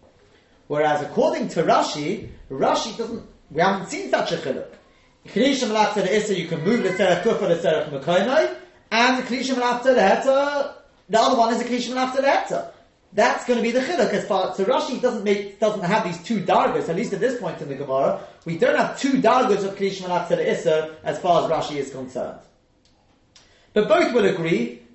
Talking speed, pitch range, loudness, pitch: 195 wpm, 175-245 Hz, -21 LUFS, 210 Hz